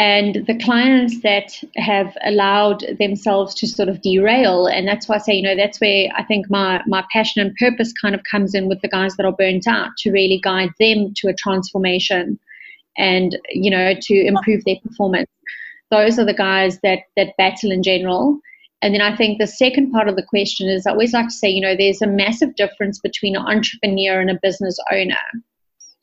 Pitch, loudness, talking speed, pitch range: 200 Hz, -17 LUFS, 205 wpm, 190-215 Hz